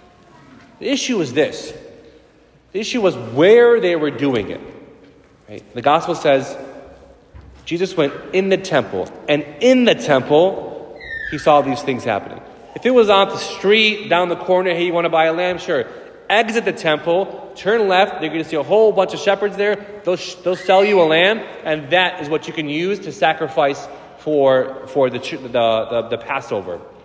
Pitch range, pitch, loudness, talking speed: 150-205 Hz, 175 Hz, -17 LUFS, 190 wpm